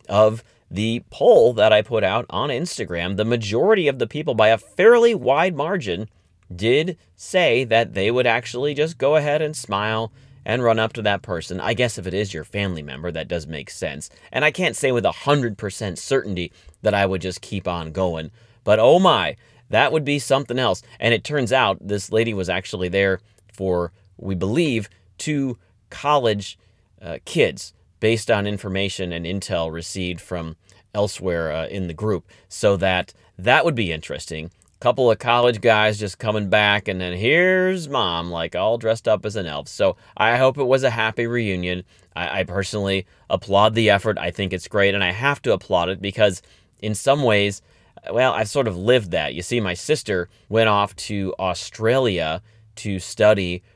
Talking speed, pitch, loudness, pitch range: 190 wpm, 100 Hz, -20 LUFS, 95-115 Hz